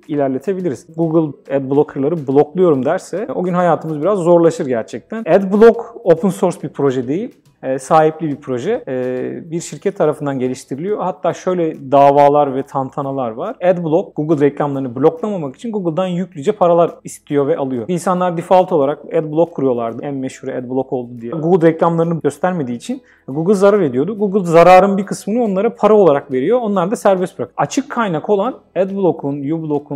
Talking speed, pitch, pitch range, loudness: 150 wpm, 165 Hz, 140-185 Hz, -16 LUFS